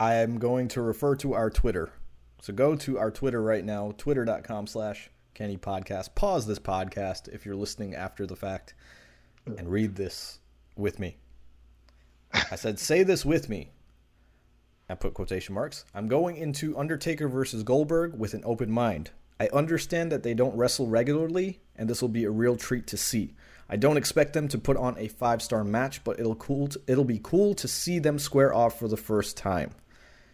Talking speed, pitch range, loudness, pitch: 190 wpm, 100-135 Hz, -28 LUFS, 110 Hz